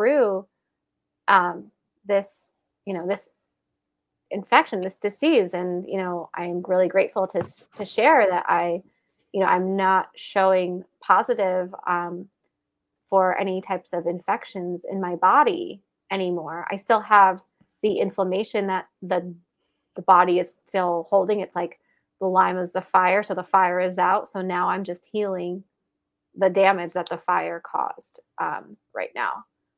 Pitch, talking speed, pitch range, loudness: 185 Hz, 150 wpm, 180-195 Hz, -23 LUFS